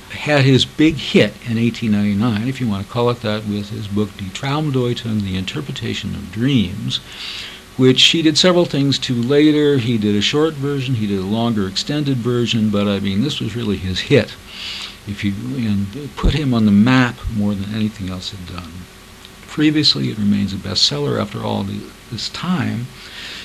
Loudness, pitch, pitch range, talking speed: -17 LUFS, 110 Hz, 100-130 Hz, 180 wpm